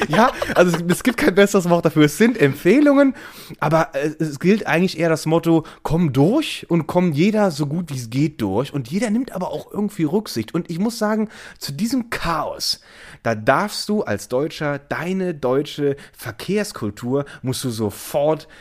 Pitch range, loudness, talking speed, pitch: 140-200 Hz, -20 LUFS, 175 wpm, 165 Hz